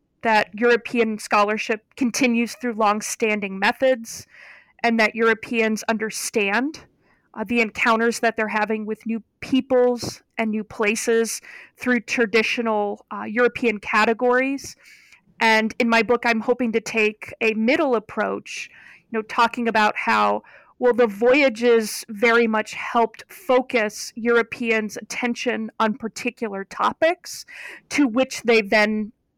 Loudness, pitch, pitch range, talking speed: -21 LUFS, 230 Hz, 220-245 Hz, 125 wpm